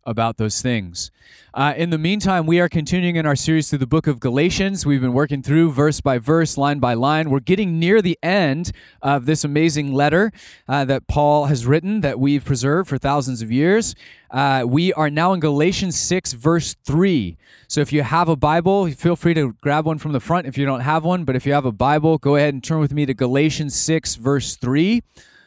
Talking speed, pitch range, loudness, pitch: 220 wpm, 135-165 Hz, -19 LUFS, 150 Hz